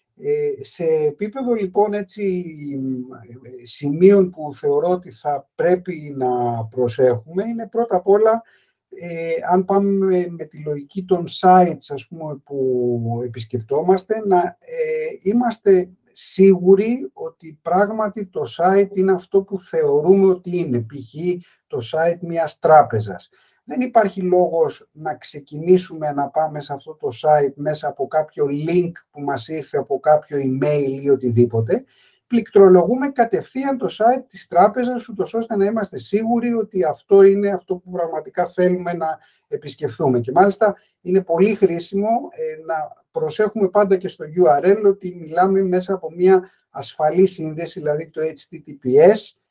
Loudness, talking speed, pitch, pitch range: -19 LUFS, 135 wpm, 180 Hz, 150-200 Hz